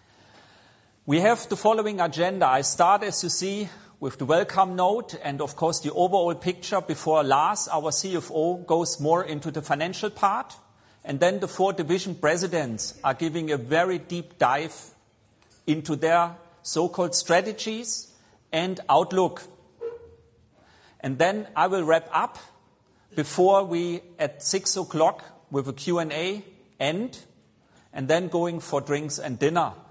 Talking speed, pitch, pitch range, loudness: 140 wpm, 170 Hz, 150-185 Hz, -25 LUFS